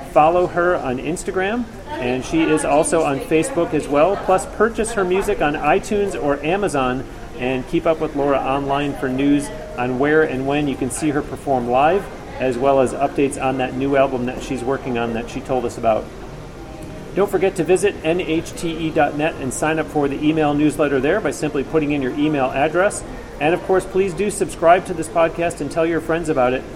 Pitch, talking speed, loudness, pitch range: 150 Hz, 200 wpm, -19 LUFS, 135-170 Hz